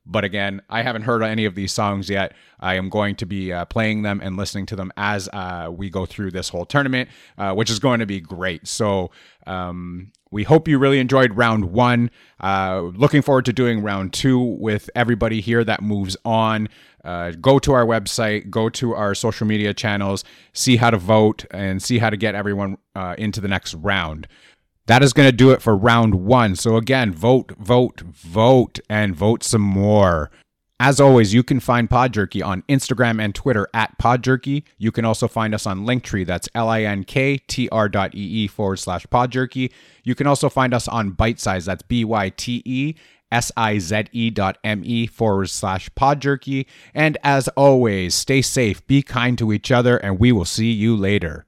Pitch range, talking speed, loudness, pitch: 100-125 Hz, 205 wpm, -19 LUFS, 110 Hz